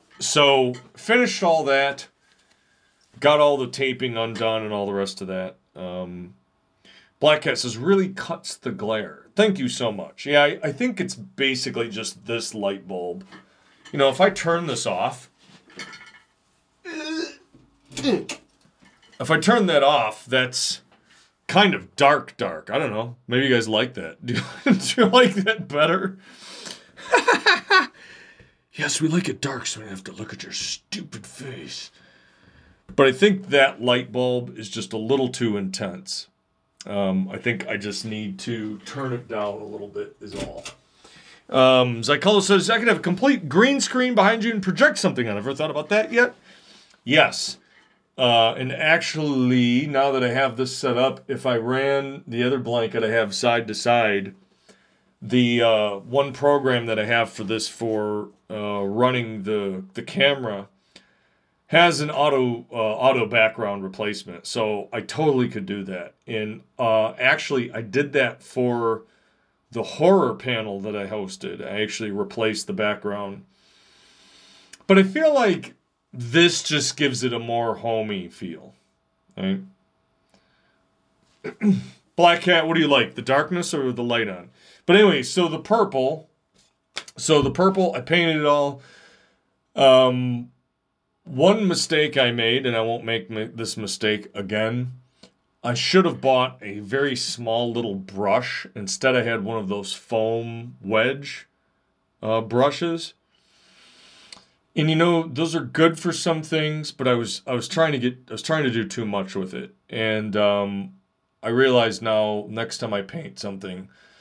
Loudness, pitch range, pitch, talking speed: -21 LUFS, 110-160 Hz, 125 Hz, 160 wpm